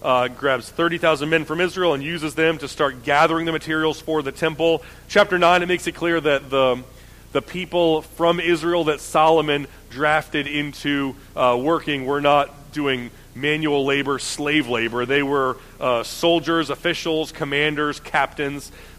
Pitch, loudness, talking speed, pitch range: 150 Hz, -20 LUFS, 160 wpm, 140-165 Hz